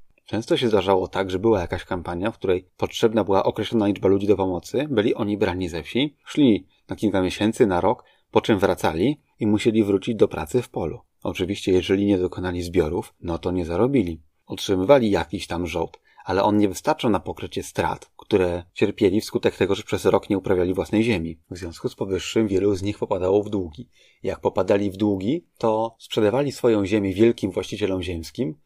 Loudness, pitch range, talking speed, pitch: -23 LUFS, 90-110 Hz, 190 wpm, 100 Hz